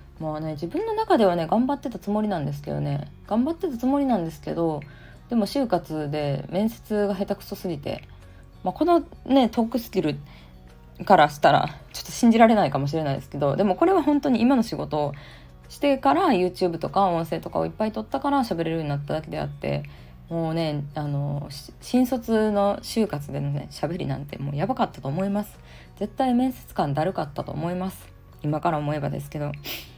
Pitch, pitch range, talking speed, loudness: 170 Hz, 145-225 Hz, 400 characters per minute, -24 LUFS